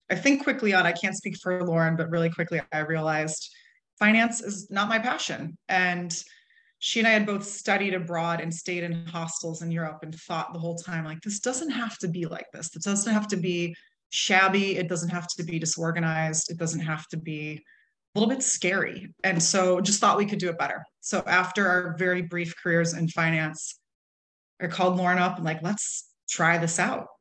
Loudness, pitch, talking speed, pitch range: -26 LUFS, 180 Hz, 205 wpm, 165-200 Hz